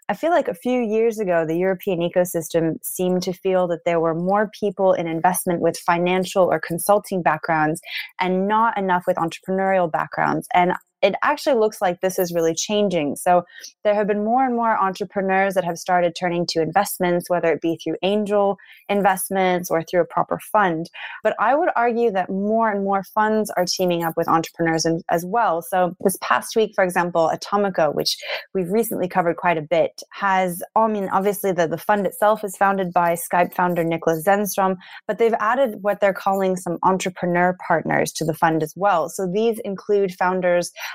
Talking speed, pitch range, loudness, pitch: 190 wpm, 175-205 Hz, -21 LUFS, 185 Hz